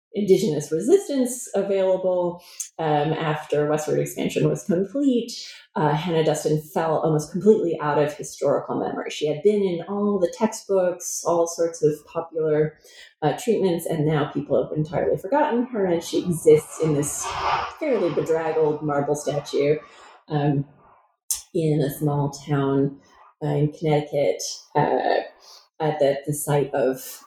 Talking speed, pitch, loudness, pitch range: 135 wpm, 155 Hz, -23 LUFS, 150-190 Hz